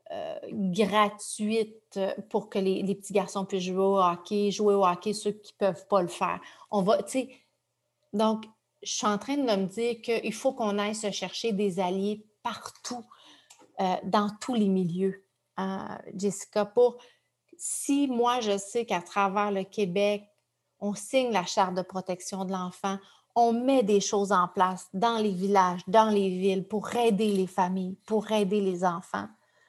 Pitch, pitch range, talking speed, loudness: 205 Hz, 190-220 Hz, 170 wpm, -28 LUFS